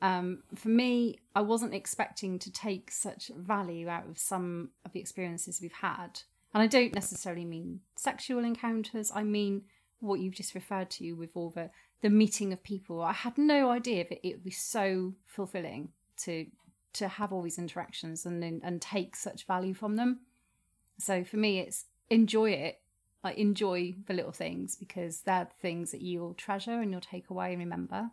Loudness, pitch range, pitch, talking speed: -33 LUFS, 175-215 Hz, 190 Hz, 190 wpm